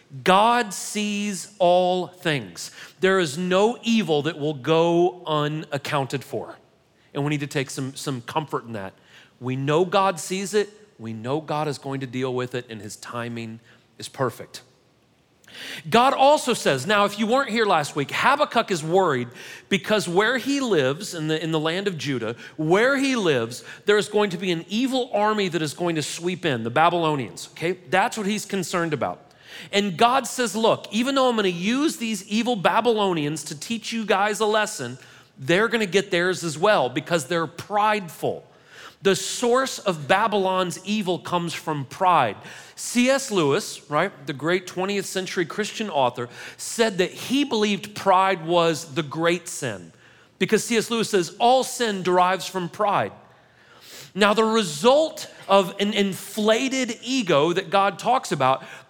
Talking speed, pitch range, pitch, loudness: 165 wpm, 155-215 Hz, 185 Hz, -22 LUFS